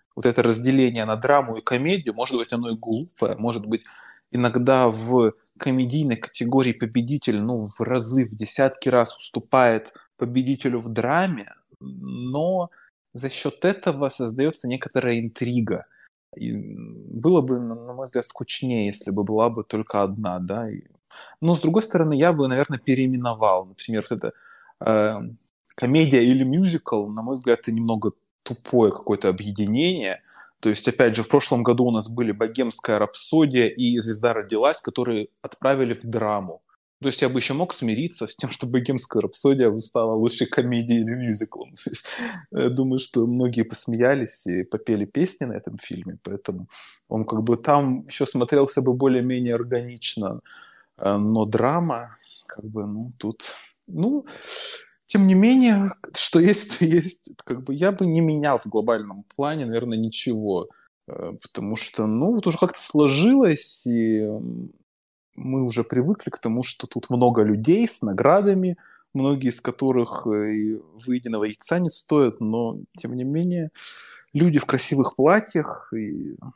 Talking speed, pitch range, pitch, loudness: 150 wpm, 115-145 Hz, 125 Hz, -22 LUFS